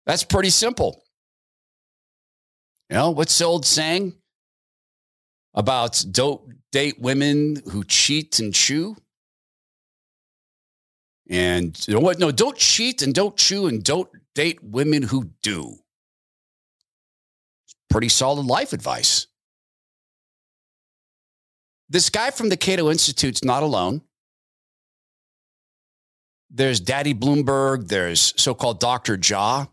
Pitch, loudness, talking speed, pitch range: 140 Hz, -19 LUFS, 110 wpm, 125-170 Hz